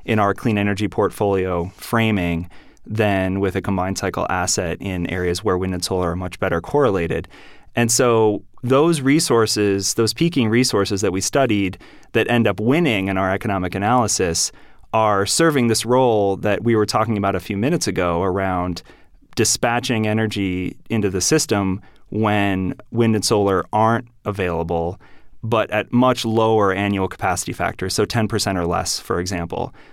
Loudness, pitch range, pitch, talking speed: -19 LUFS, 95-115 Hz, 100 Hz, 155 wpm